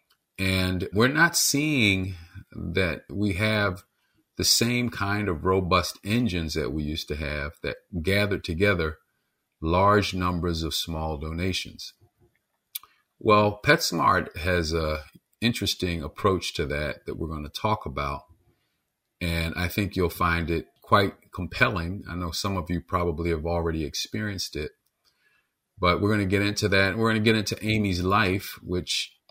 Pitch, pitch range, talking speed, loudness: 90 Hz, 85-105 Hz, 150 wpm, -25 LUFS